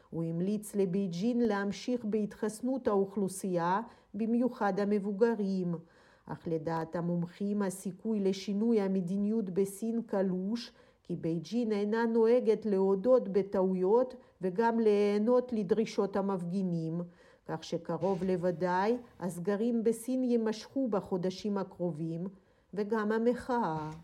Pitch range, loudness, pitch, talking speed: 185-230 Hz, -32 LUFS, 200 Hz, 90 wpm